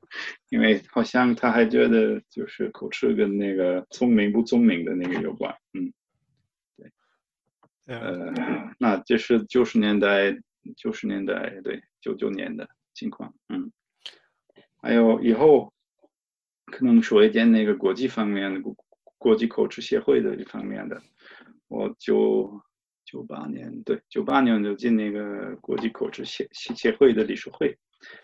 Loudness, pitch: -23 LUFS, 130 Hz